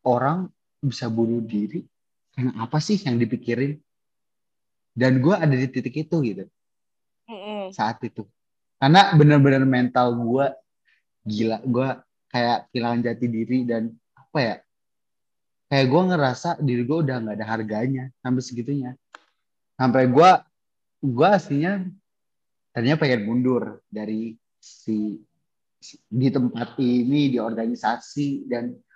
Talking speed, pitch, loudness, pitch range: 120 wpm, 125 Hz, -22 LUFS, 115-140 Hz